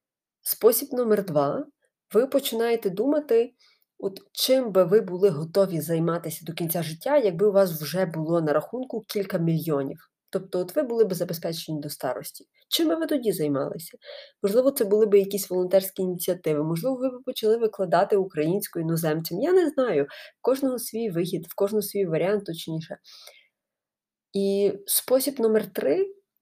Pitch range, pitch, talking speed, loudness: 170-245 Hz, 200 Hz, 155 wpm, -25 LUFS